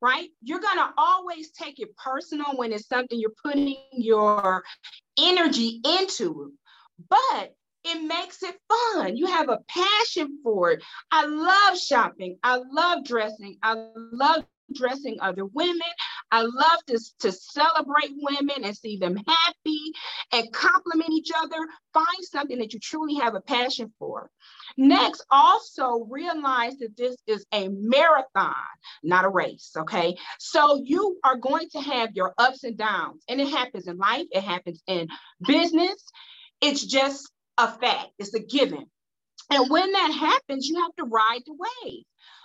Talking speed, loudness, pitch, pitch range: 155 wpm, -24 LUFS, 275 Hz, 225-330 Hz